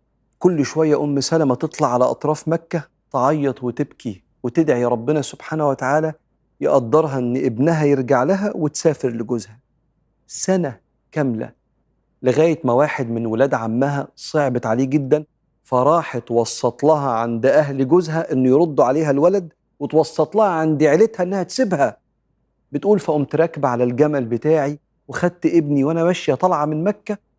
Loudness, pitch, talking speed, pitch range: -19 LUFS, 150 Hz, 135 wpm, 130-160 Hz